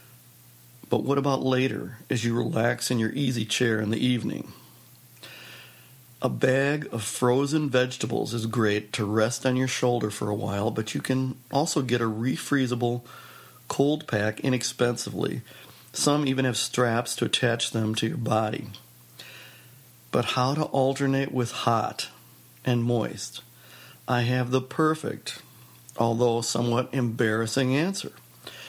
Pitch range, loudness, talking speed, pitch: 110-130 Hz, -26 LUFS, 135 wpm, 125 Hz